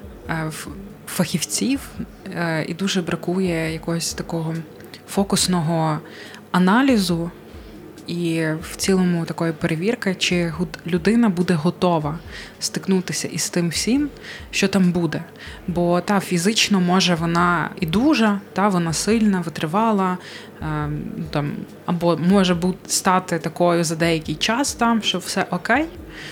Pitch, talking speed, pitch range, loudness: 180 Hz, 105 wpm, 170-195 Hz, -21 LUFS